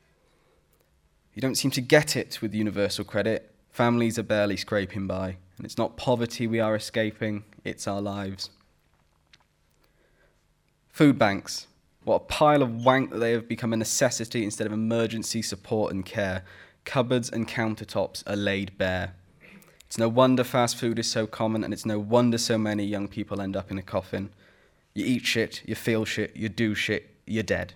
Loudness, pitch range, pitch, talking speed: -26 LUFS, 100-115 Hz, 110 Hz, 175 wpm